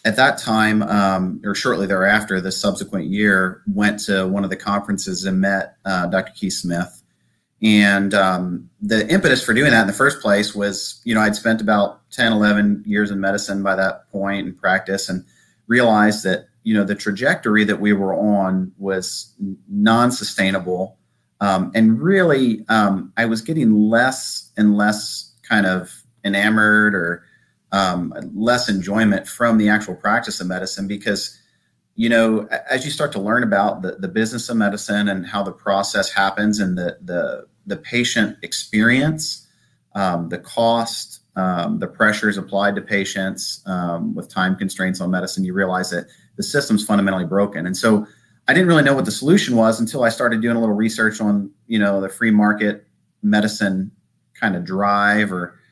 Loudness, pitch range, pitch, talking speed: -18 LUFS, 95-110 Hz, 105 Hz, 170 wpm